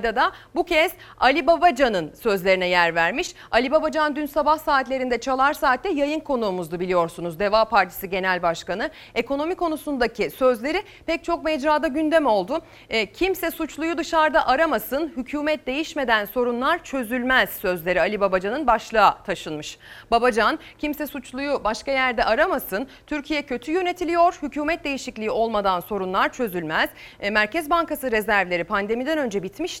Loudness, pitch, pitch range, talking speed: -22 LUFS, 265 Hz, 210-315 Hz, 130 wpm